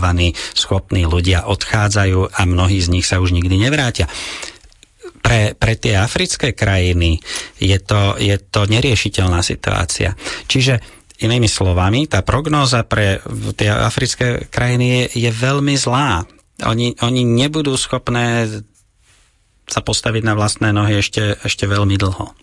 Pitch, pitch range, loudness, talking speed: 105 Hz, 95-120 Hz, -16 LUFS, 130 wpm